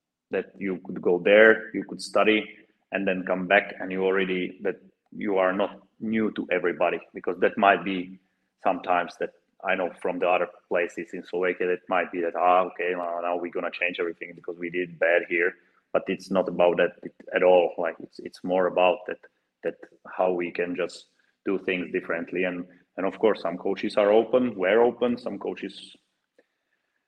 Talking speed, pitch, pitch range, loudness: 195 wpm, 95 Hz, 90-105 Hz, -25 LUFS